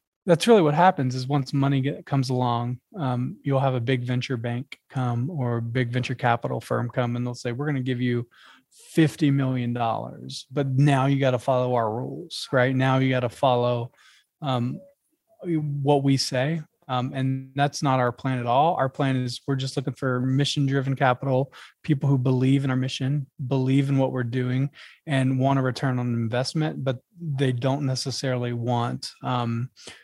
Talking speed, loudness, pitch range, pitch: 185 wpm, -24 LUFS, 125-140 Hz, 130 Hz